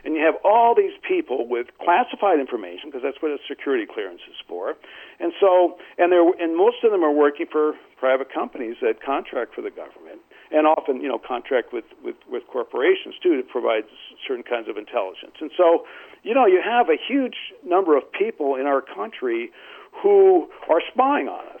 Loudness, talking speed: -21 LUFS, 195 wpm